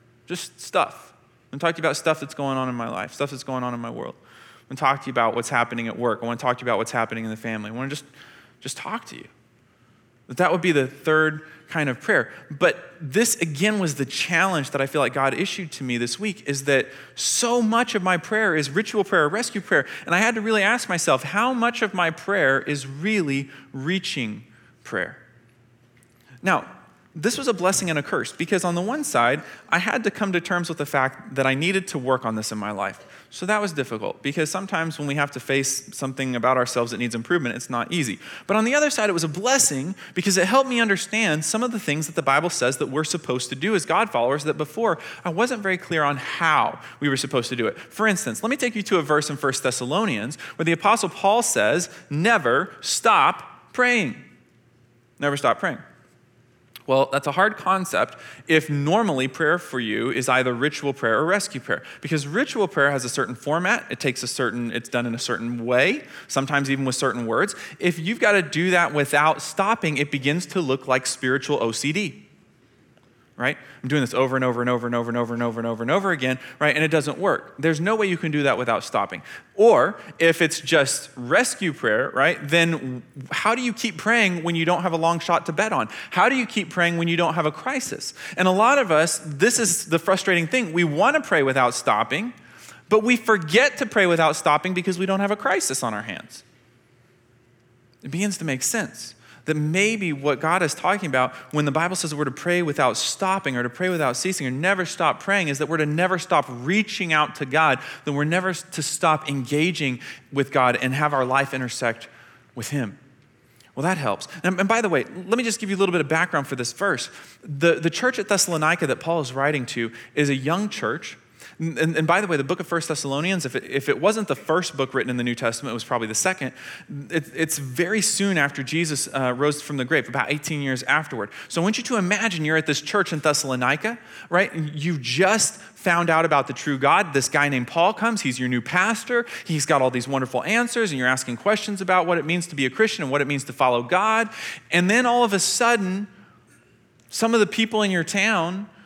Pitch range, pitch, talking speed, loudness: 130-190 Hz, 155 Hz, 235 wpm, -22 LUFS